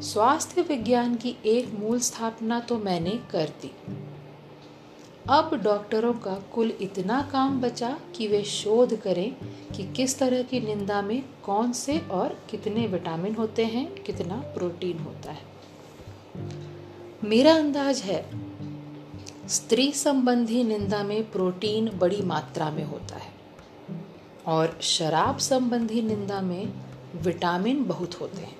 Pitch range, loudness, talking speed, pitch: 175-240 Hz, -26 LUFS, 125 wpm, 210 Hz